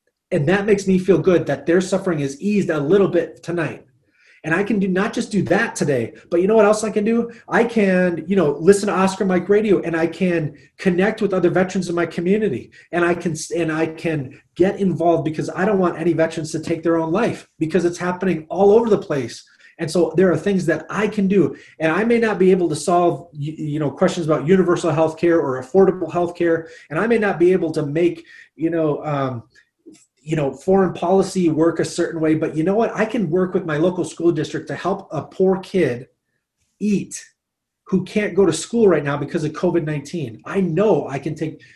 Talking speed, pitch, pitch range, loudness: 225 wpm, 175 Hz, 160-195 Hz, -19 LUFS